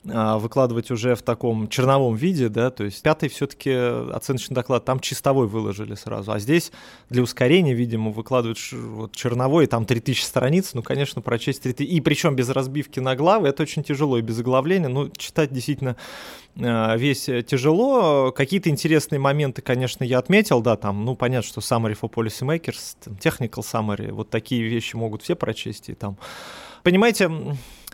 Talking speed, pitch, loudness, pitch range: 160 wpm, 125 Hz, -22 LUFS, 115-145 Hz